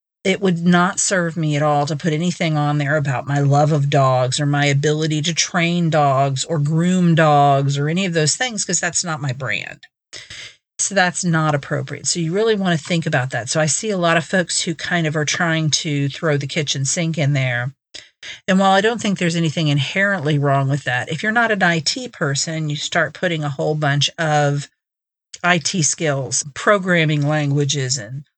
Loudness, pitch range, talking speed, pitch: -18 LUFS, 145-175 Hz, 205 wpm, 155 Hz